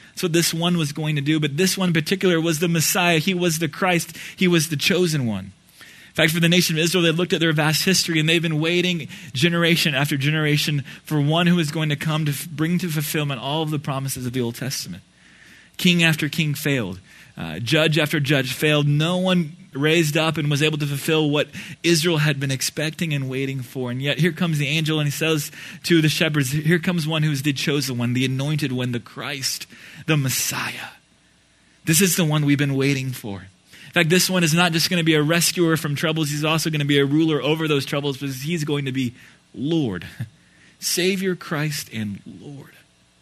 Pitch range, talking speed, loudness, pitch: 140-170 Hz, 220 wpm, -20 LUFS, 155 Hz